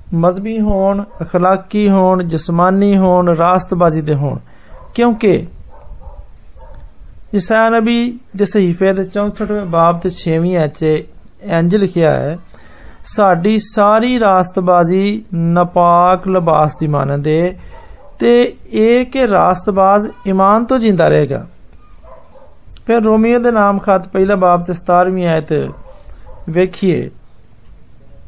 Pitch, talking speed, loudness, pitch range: 185 Hz, 105 wpm, -13 LUFS, 165-205 Hz